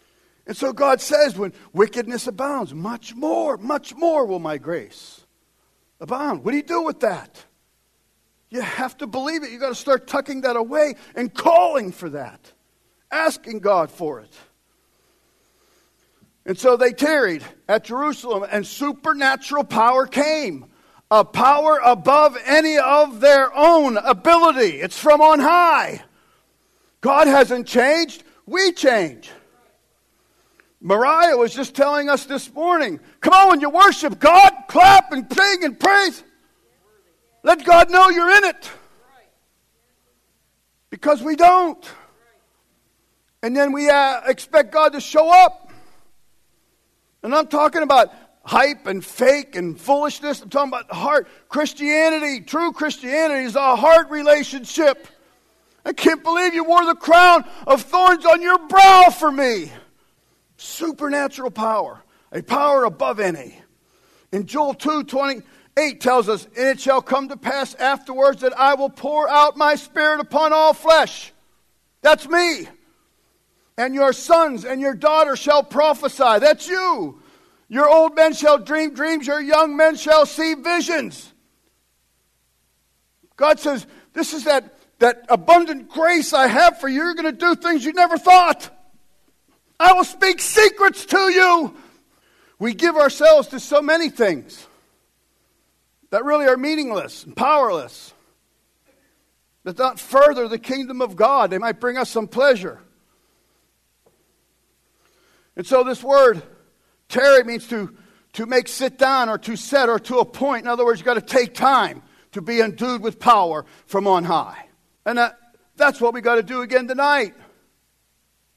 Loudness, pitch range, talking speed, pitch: -16 LUFS, 250-320 Hz, 145 wpm, 285 Hz